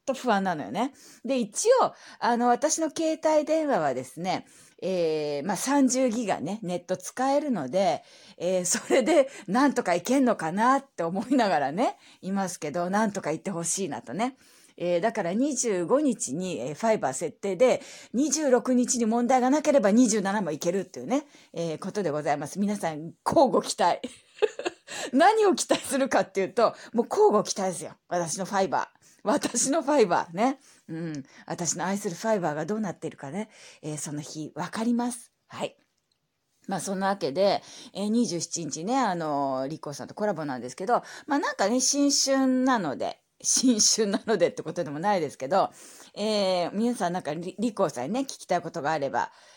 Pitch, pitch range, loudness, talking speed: 215 Hz, 175-260 Hz, -26 LUFS, 340 characters per minute